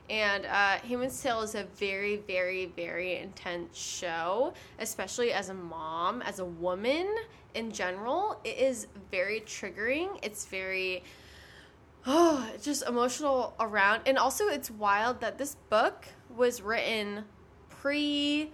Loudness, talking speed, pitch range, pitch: -31 LUFS, 135 wpm, 190-270 Hz, 220 Hz